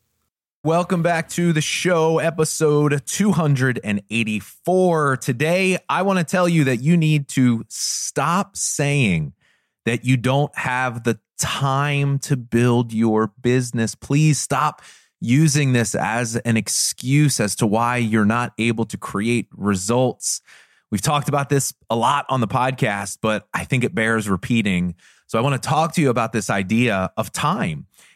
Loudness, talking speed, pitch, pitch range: -20 LUFS, 155 wpm, 130 Hz, 115-150 Hz